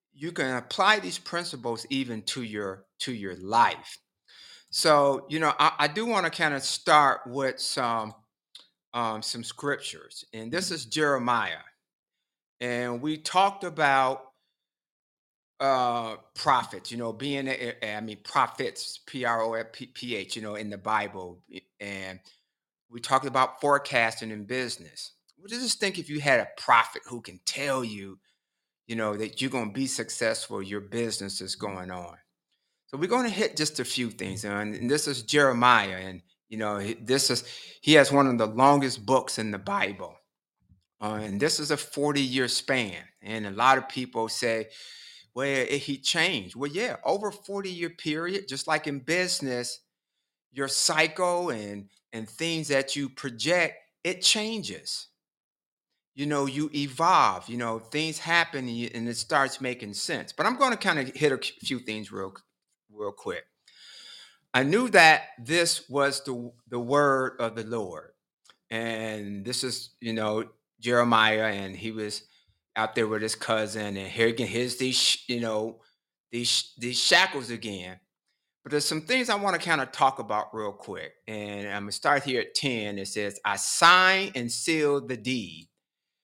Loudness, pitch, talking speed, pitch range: -26 LUFS, 125 Hz, 170 wpm, 110-145 Hz